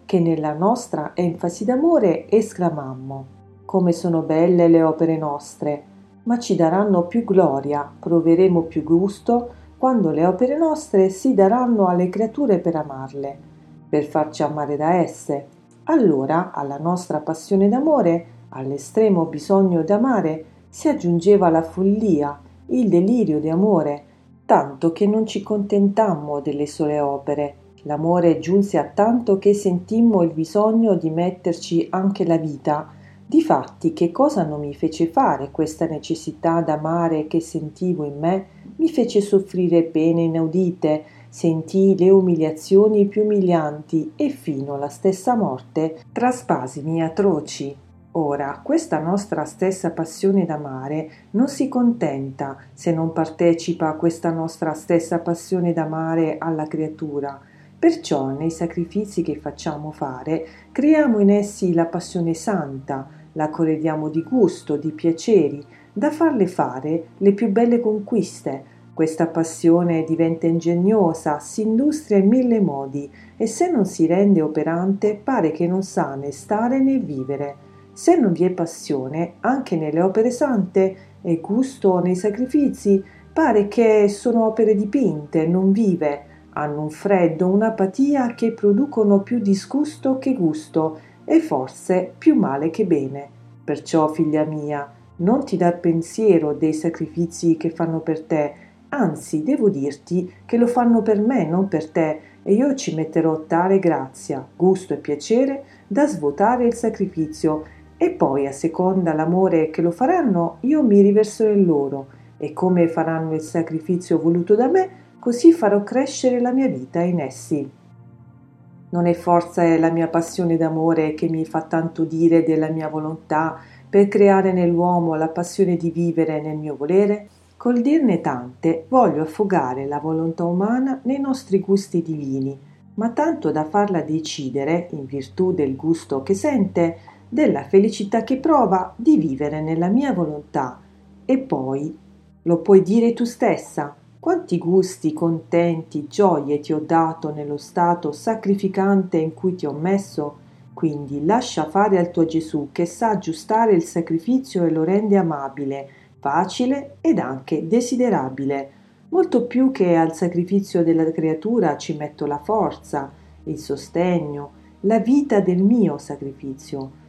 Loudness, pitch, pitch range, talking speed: -20 LUFS, 170 Hz, 155-205 Hz, 140 wpm